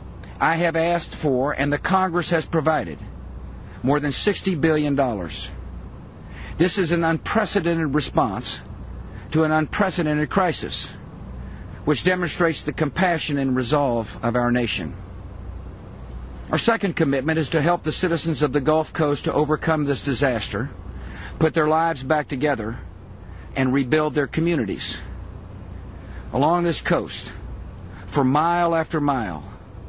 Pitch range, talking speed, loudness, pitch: 95-160 Hz, 125 wpm, -22 LUFS, 140 Hz